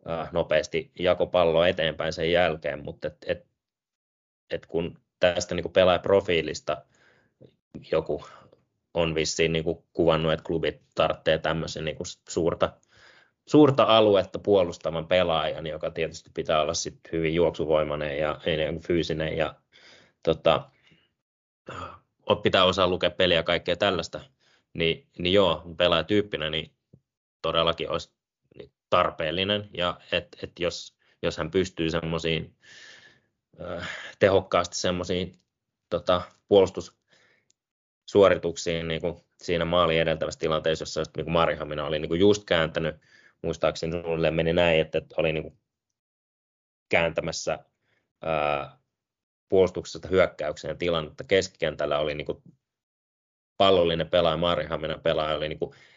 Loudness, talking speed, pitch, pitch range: -25 LUFS, 115 wpm, 80 Hz, 80-90 Hz